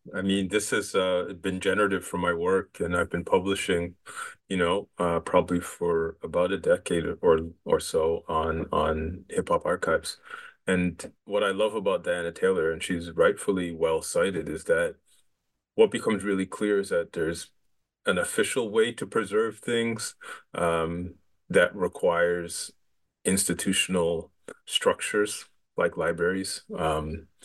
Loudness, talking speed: -27 LUFS, 140 wpm